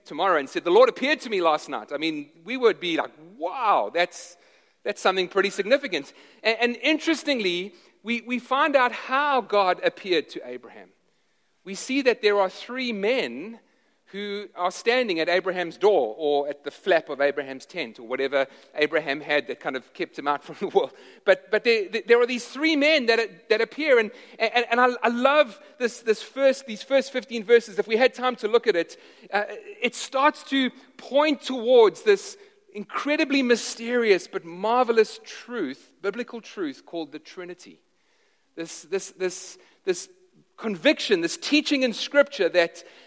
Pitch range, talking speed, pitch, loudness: 185-280 Hz, 170 wpm, 235 Hz, -24 LUFS